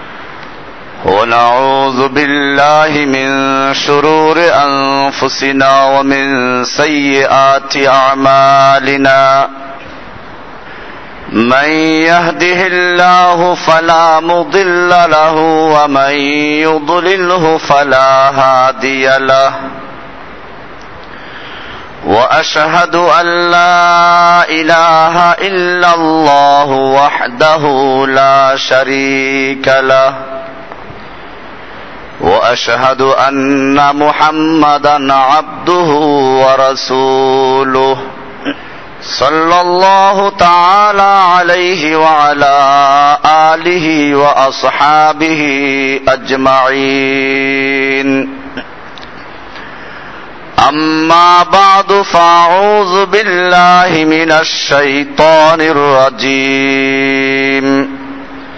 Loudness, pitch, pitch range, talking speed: -8 LUFS, 145 Hz, 135-165 Hz, 50 wpm